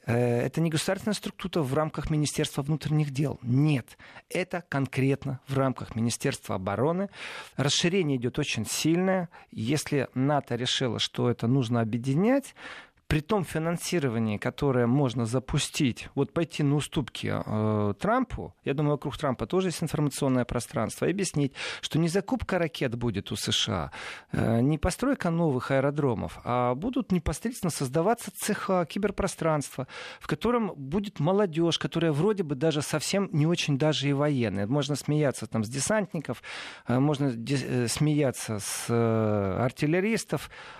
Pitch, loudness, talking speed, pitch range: 145 Hz, -28 LUFS, 140 wpm, 125-170 Hz